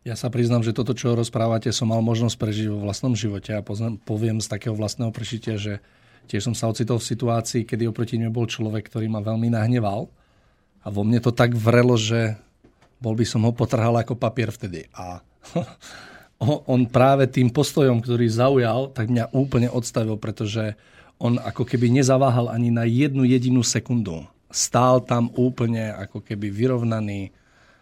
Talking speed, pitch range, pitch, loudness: 170 wpm, 110-125 Hz, 115 Hz, -22 LUFS